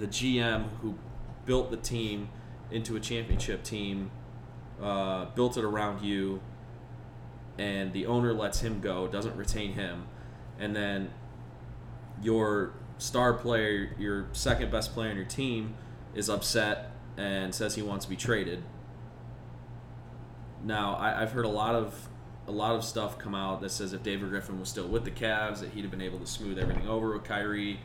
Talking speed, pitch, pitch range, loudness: 170 wpm, 110 Hz, 100-120 Hz, -32 LUFS